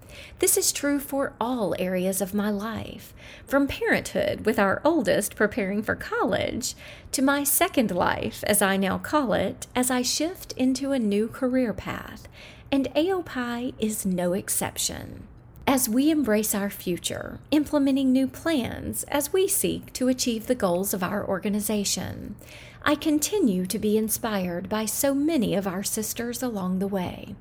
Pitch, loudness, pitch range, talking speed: 245 Hz, -25 LUFS, 205-280 Hz, 155 wpm